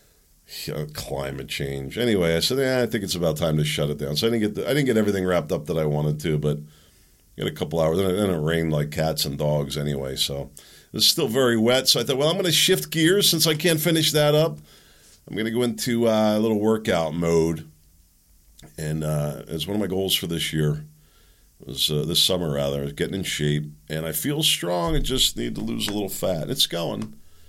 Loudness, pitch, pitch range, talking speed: -22 LUFS, 80 Hz, 75-115 Hz, 240 wpm